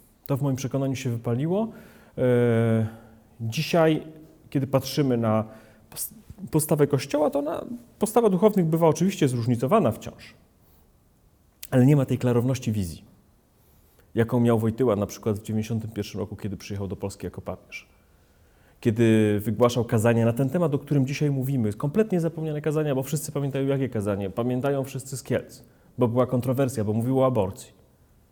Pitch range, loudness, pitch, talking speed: 110-150 Hz, -25 LUFS, 130 Hz, 145 wpm